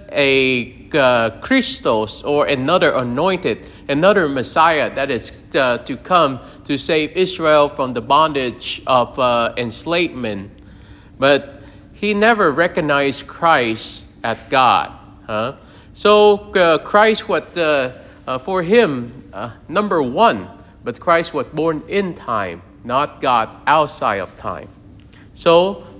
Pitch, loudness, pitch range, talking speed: 140 Hz, -17 LUFS, 110-170 Hz, 120 wpm